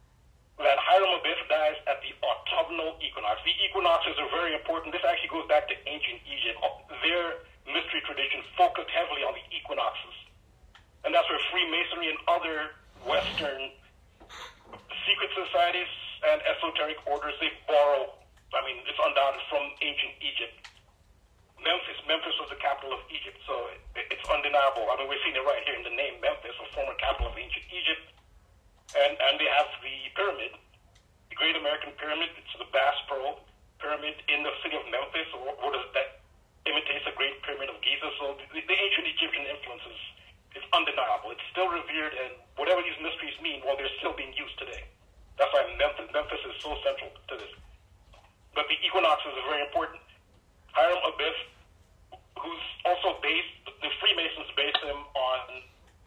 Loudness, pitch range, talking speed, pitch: -29 LUFS, 135-170 Hz, 165 wpm, 150 Hz